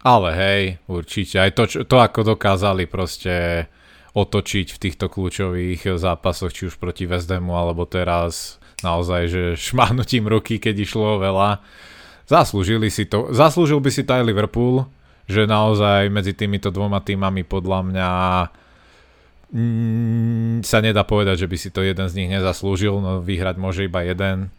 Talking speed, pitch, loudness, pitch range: 145 wpm, 95 Hz, -19 LUFS, 90-110 Hz